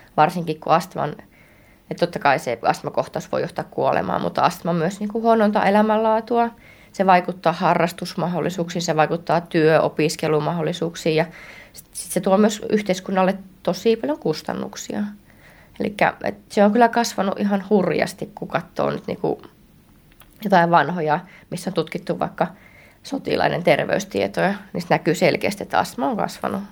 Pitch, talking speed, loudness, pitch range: 185 Hz, 135 wpm, -21 LUFS, 165-210 Hz